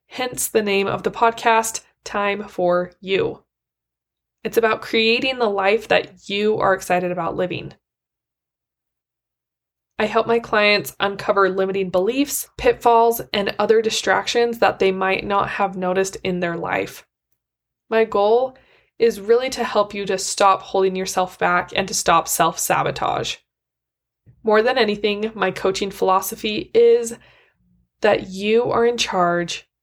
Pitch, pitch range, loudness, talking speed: 205 Hz, 190-230 Hz, -19 LUFS, 140 wpm